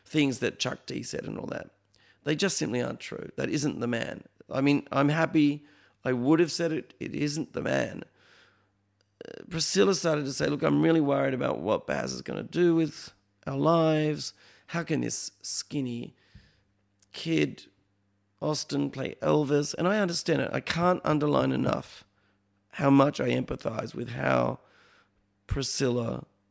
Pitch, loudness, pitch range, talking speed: 140 Hz, -28 LUFS, 100-155 Hz, 165 wpm